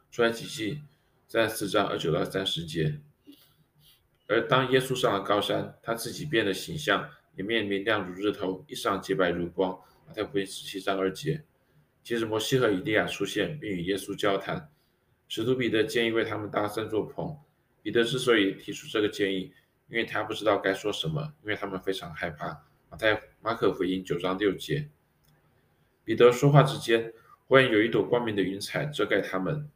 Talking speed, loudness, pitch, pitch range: 280 characters per minute, -28 LUFS, 110 Hz, 95-130 Hz